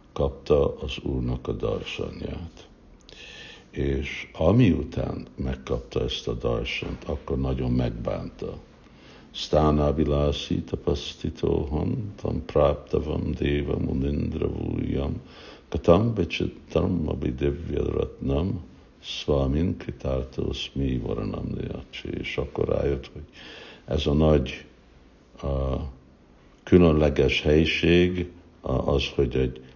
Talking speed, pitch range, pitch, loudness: 85 wpm, 65-80 Hz, 70 Hz, -26 LUFS